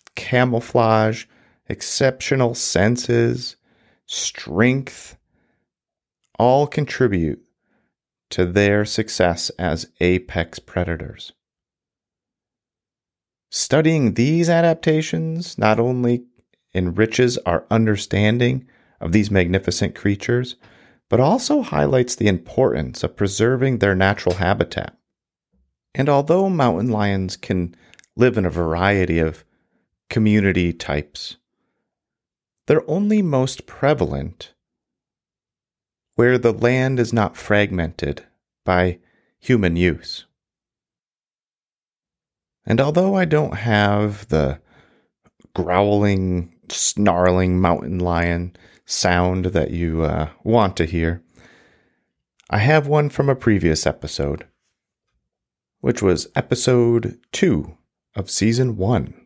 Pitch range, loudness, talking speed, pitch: 90-125 Hz, -19 LUFS, 90 wpm, 105 Hz